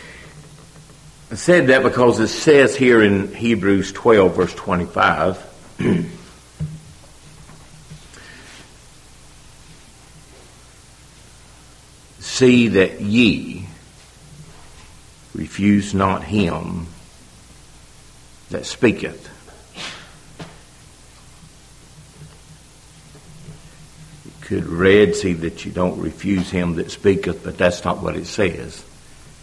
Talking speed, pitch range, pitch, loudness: 75 wpm, 90-150 Hz, 105 Hz, -17 LUFS